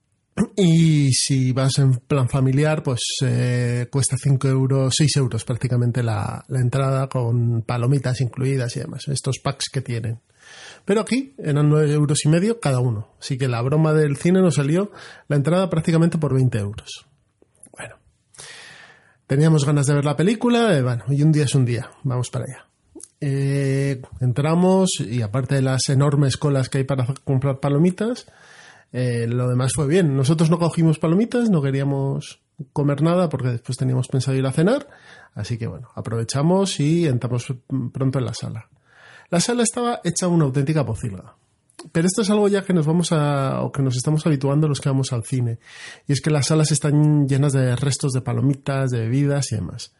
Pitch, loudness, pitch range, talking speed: 140 Hz, -20 LUFS, 130-155 Hz, 180 wpm